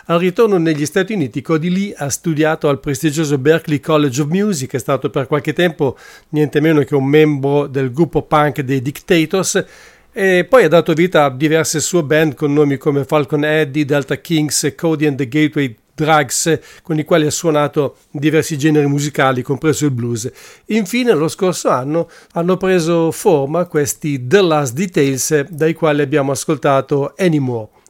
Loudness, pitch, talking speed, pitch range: -15 LUFS, 155 Hz, 170 wpm, 145-165 Hz